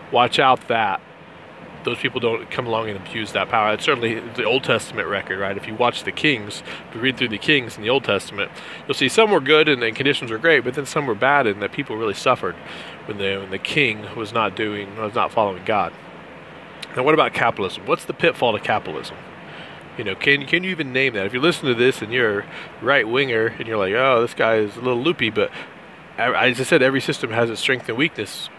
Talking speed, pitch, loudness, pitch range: 235 wpm, 120 Hz, -20 LUFS, 110-135 Hz